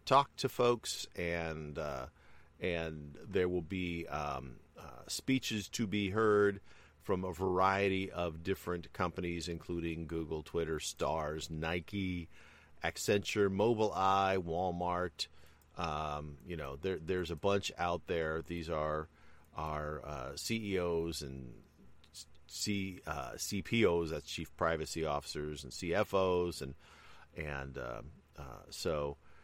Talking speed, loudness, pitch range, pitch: 120 wpm, -36 LUFS, 75-95 Hz, 85 Hz